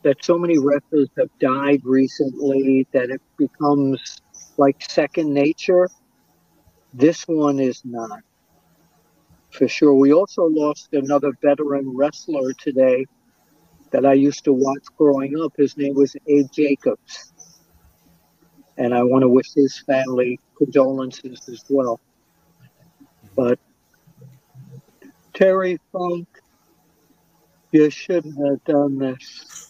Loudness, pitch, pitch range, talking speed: -19 LUFS, 140 Hz, 135-150 Hz, 115 wpm